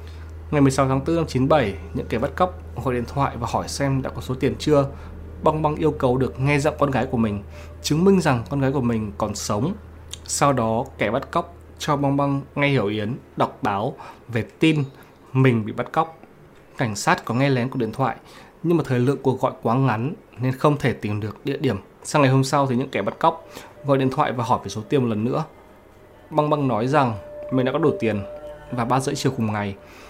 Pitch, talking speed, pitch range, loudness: 130 Hz, 235 wpm, 110-140 Hz, -22 LUFS